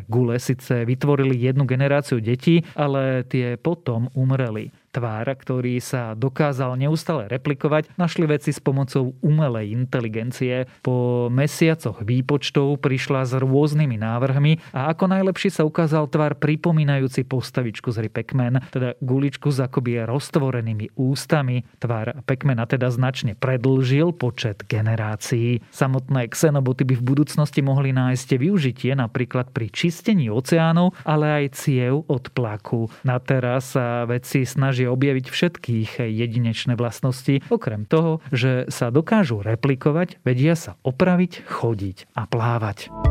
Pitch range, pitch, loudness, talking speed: 125-150 Hz, 130 Hz, -22 LUFS, 130 wpm